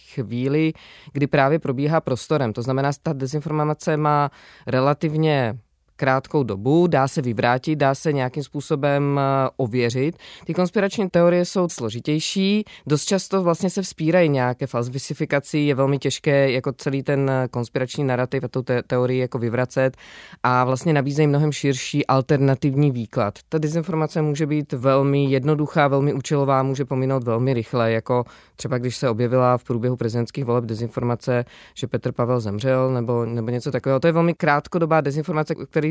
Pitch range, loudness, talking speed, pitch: 125-155 Hz, -21 LUFS, 150 wpm, 140 Hz